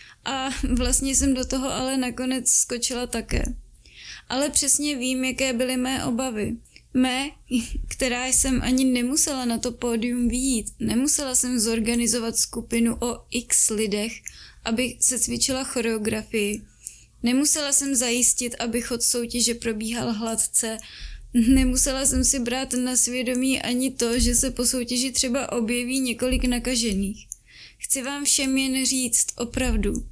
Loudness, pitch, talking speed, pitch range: -21 LUFS, 250 Hz, 130 wpm, 235-260 Hz